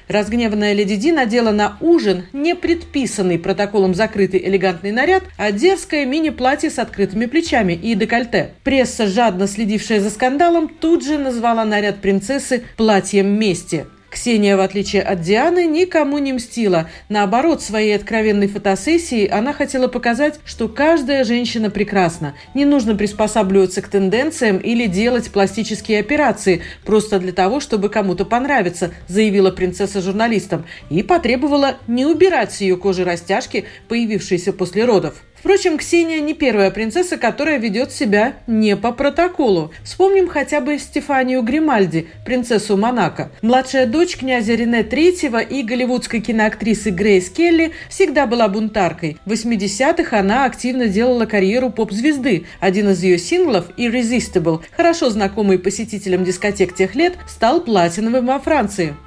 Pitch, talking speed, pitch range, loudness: 225 Hz, 135 wpm, 200-270 Hz, -16 LUFS